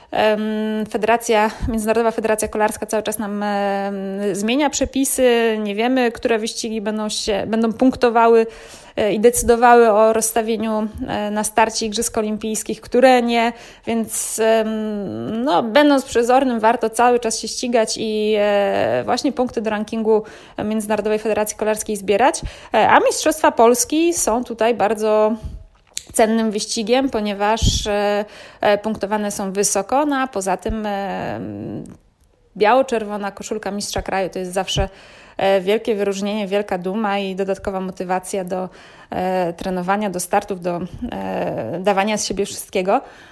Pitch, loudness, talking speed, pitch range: 215 Hz, -19 LUFS, 115 wpm, 200-230 Hz